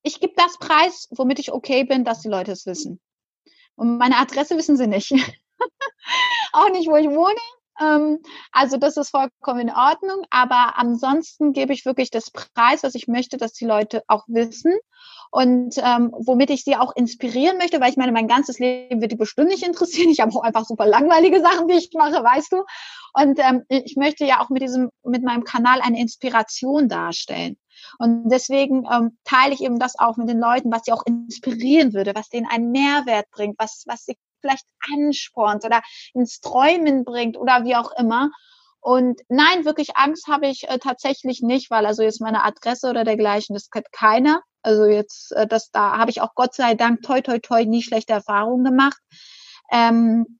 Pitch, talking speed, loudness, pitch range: 255 Hz, 190 wpm, -19 LUFS, 235-290 Hz